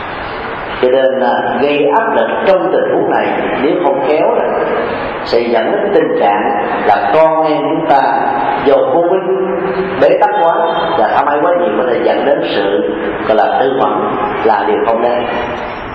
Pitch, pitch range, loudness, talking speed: 155 Hz, 120-170 Hz, -12 LUFS, 175 wpm